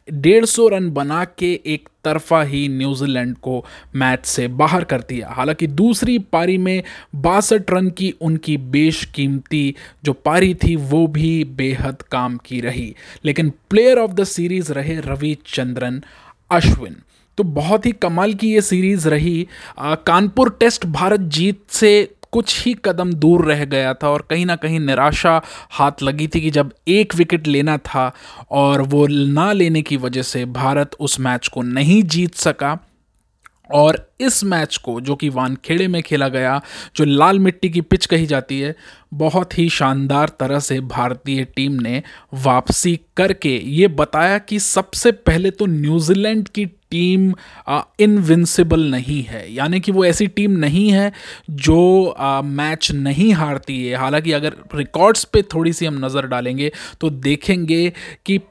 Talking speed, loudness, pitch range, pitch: 160 wpm, -17 LUFS, 140-185 Hz, 155 Hz